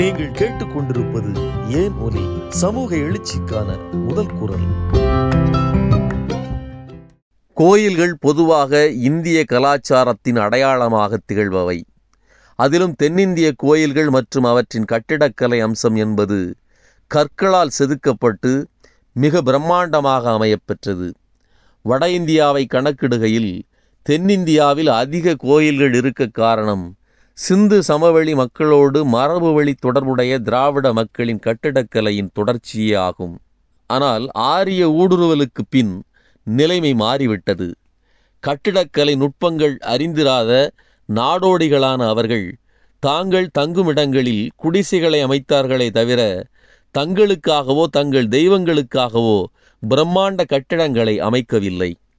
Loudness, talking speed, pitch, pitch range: -16 LUFS, 75 wpm, 130 Hz, 110-150 Hz